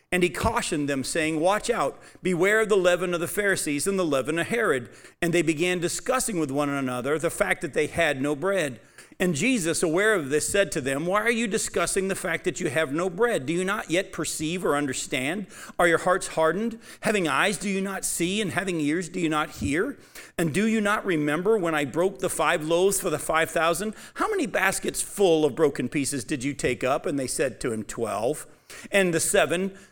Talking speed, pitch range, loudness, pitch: 225 wpm, 160-200 Hz, -25 LUFS, 175 Hz